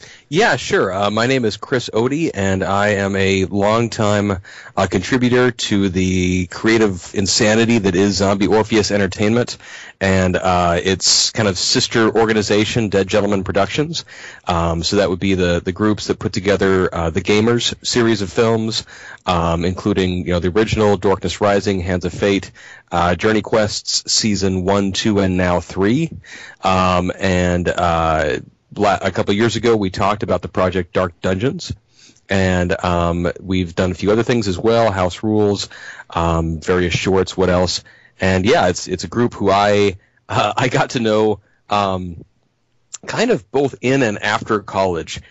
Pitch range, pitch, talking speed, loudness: 90-110 Hz, 100 Hz, 165 wpm, -17 LUFS